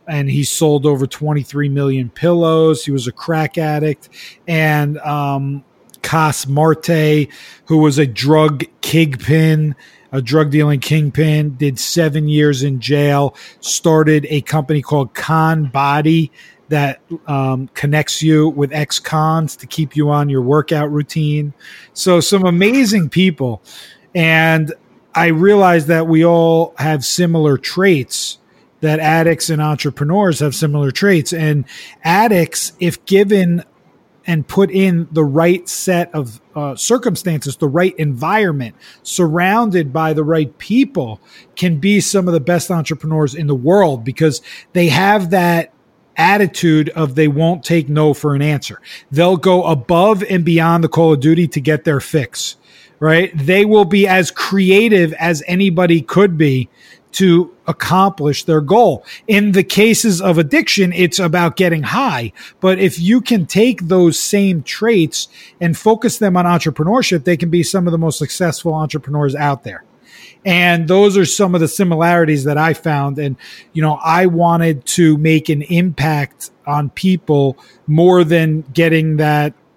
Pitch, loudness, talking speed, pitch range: 160 Hz, -14 LUFS, 150 wpm, 150-180 Hz